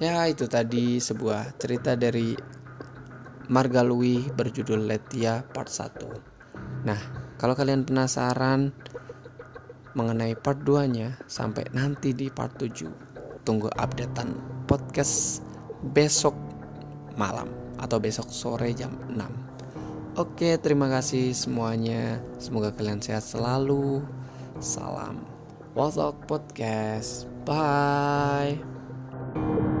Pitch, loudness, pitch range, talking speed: 130 Hz, -27 LUFS, 115-140 Hz, 95 wpm